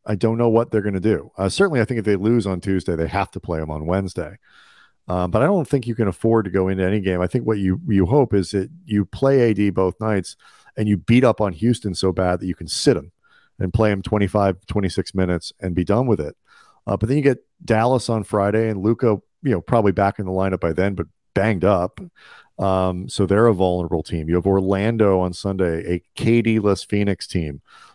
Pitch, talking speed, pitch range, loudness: 100 Hz, 240 wpm, 95-110 Hz, -20 LUFS